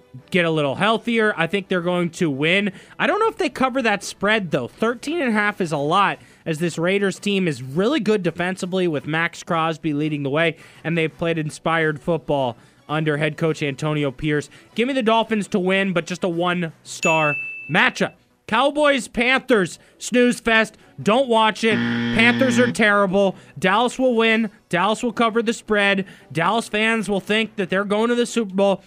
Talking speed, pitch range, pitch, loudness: 190 wpm, 160-225 Hz, 190 Hz, -20 LUFS